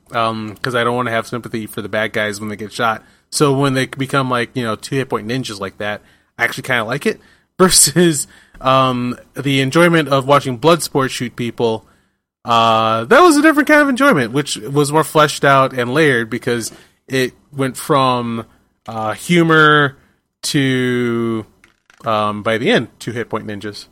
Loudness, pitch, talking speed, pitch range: -15 LUFS, 125 Hz, 190 wpm, 110-145 Hz